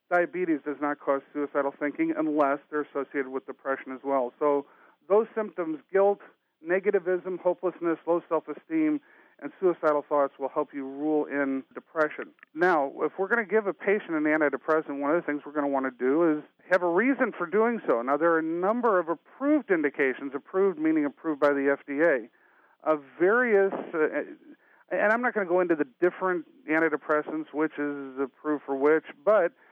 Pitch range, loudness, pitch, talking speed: 145-185 Hz, -27 LUFS, 155 Hz, 180 wpm